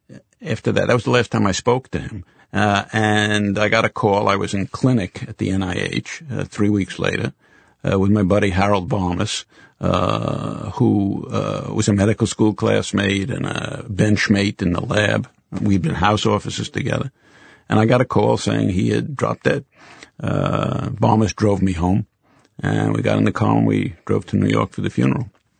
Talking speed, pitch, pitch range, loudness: 195 wpm, 105 Hz, 100-115 Hz, -19 LUFS